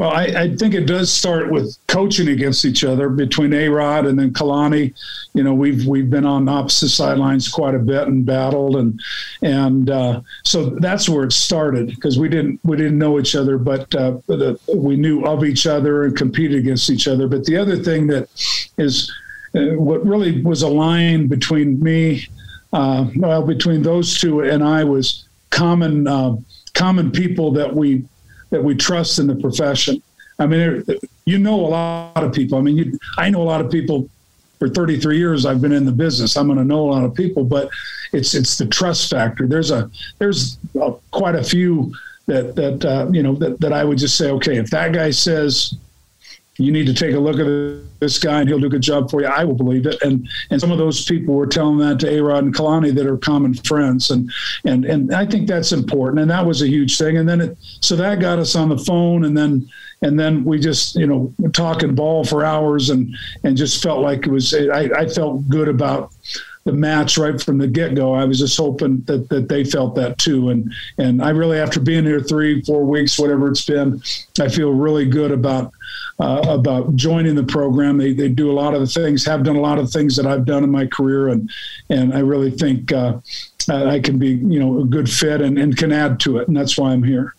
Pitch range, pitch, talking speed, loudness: 135-155 Hz, 145 Hz, 225 wpm, -16 LUFS